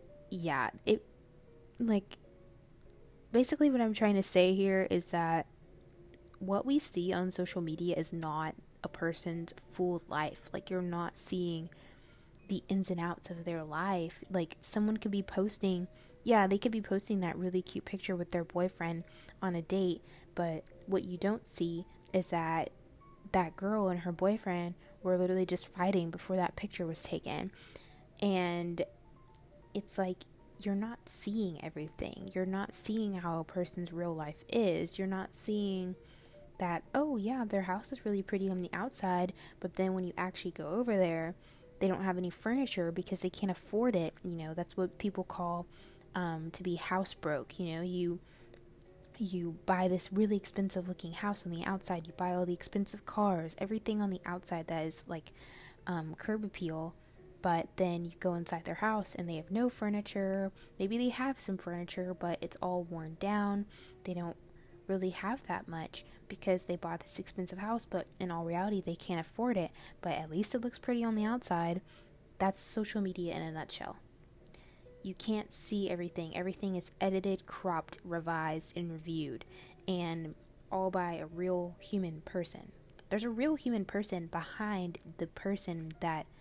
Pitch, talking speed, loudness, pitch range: 180 Hz, 170 wpm, -35 LUFS, 170-195 Hz